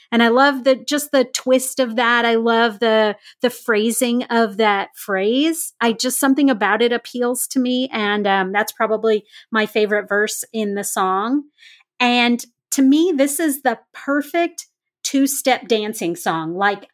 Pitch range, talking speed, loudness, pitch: 215-270 Hz, 165 wpm, -18 LUFS, 240 Hz